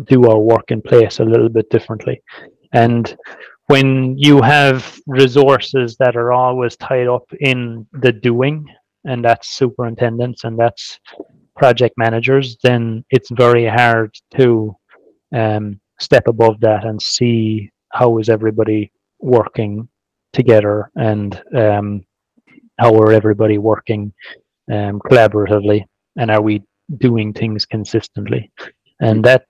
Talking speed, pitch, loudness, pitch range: 125 wpm, 115 Hz, -14 LUFS, 110-125 Hz